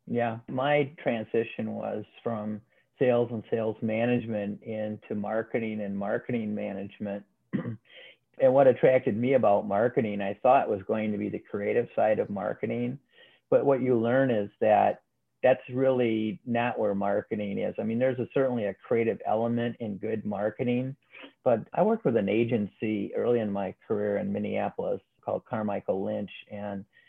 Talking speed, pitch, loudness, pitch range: 155 wpm, 110 Hz, -28 LUFS, 105-120 Hz